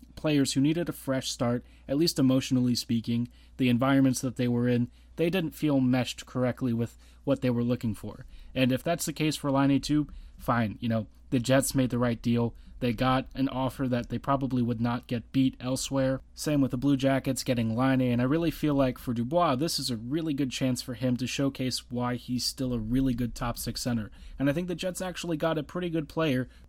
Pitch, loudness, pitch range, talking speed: 130 Hz, -28 LUFS, 120-140 Hz, 225 wpm